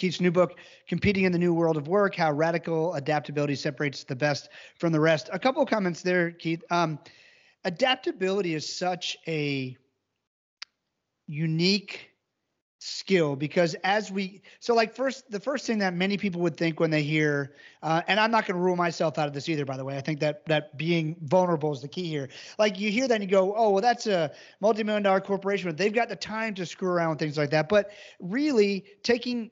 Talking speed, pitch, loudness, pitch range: 210 wpm, 180 Hz, -26 LUFS, 155-205 Hz